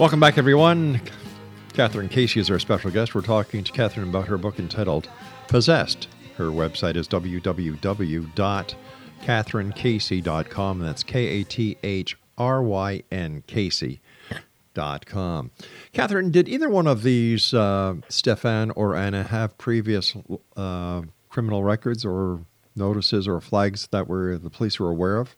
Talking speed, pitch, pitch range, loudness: 125 wpm, 100 Hz, 95-115 Hz, -23 LUFS